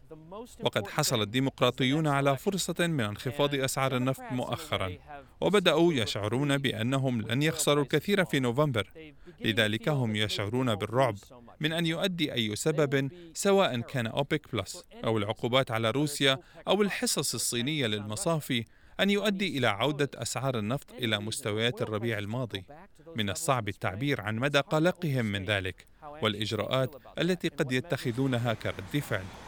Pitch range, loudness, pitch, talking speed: 110-150 Hz, -29 LUFS, 130 Hz, 130 wpm